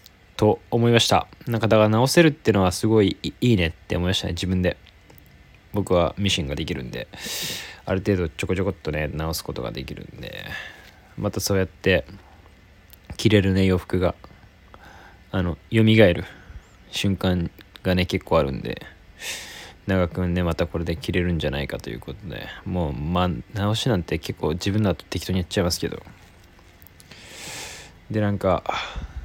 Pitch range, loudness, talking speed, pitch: 85-100 Hz, -23 LUFS, 310 characters per minute, 90 Hz